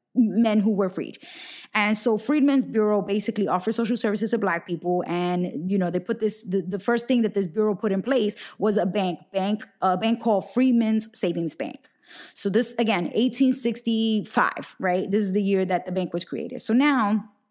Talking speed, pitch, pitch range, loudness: 195 wpm, 215 Hz, 195-235 Hz, -24 LUFS